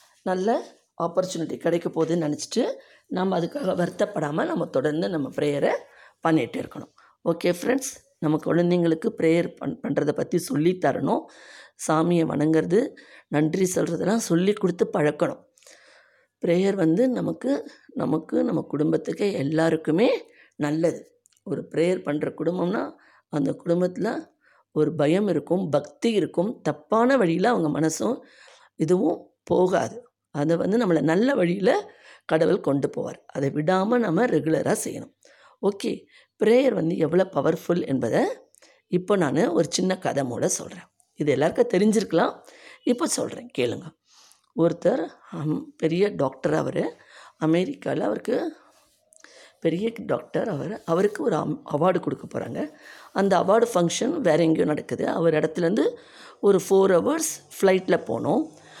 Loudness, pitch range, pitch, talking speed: -24 LUFS, 160-210 Hz, 175 Hz, 115 wpm